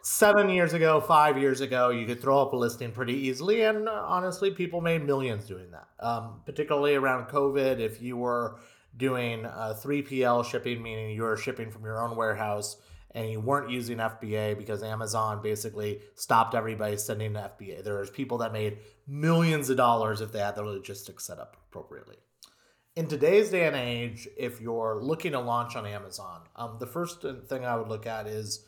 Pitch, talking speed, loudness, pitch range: 120 Hz, 185 wpm, -28 LUFS, 110-140 Hz